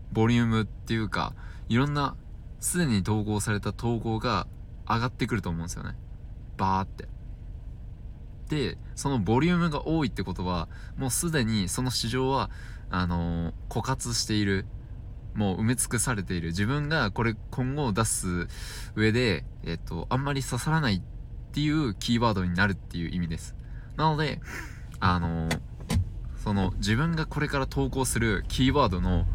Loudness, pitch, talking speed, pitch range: -28 LUFS, 110 Hz, 320 characters per minute, 95-125 Hz